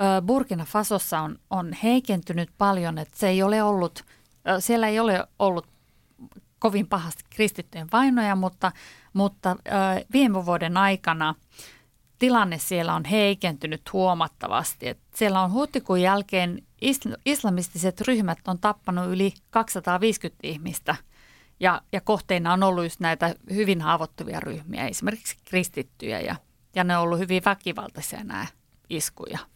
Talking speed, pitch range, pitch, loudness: 130 wpm, 175-210 Hz, 190 Hz, -25 LUFS